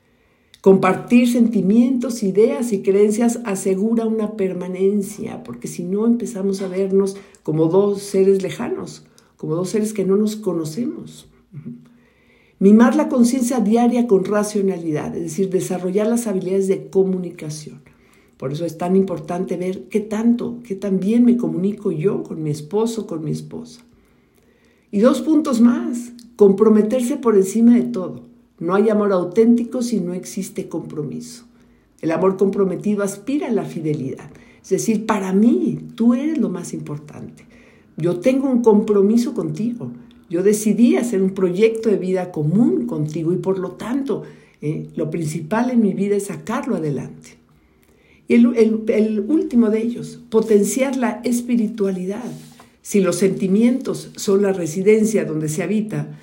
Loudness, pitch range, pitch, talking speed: -19 LUFS, 185-230 Hz, 200 Hz, 145 wpm